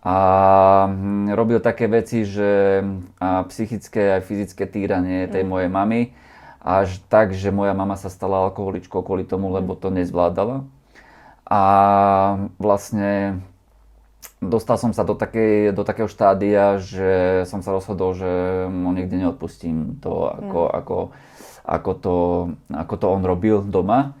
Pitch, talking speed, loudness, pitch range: 95 Hz, 130 wpm, -20 LUFS, 95-105 Hz